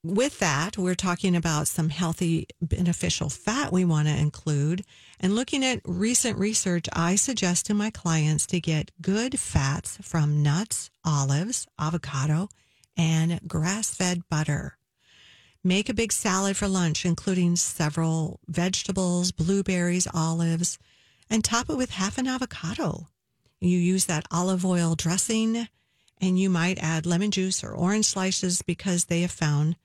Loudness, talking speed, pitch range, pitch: -25 LUFS, 145 wpm, 165-195 Hz, 180 Hz